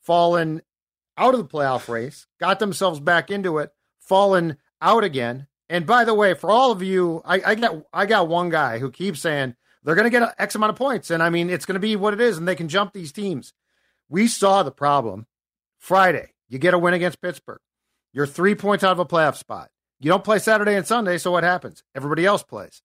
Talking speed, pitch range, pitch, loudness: 230 wpm, 155-200 Hz, 180 Hz, -20 LUFS